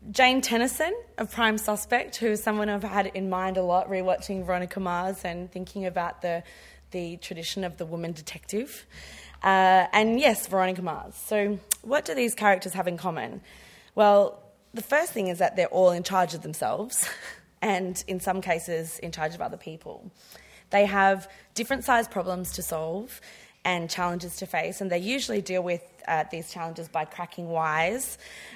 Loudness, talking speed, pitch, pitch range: -27 LUFS, 175 wpm, 185 Hz, 175-210 Hz